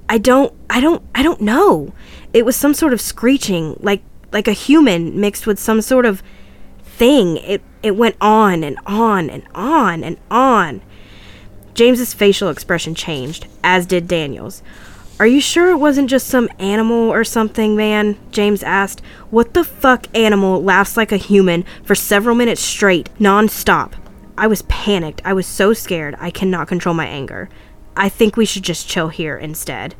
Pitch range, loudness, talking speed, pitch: 175-230 Hz, -15 LUFS, 170 wpm, 205 Hz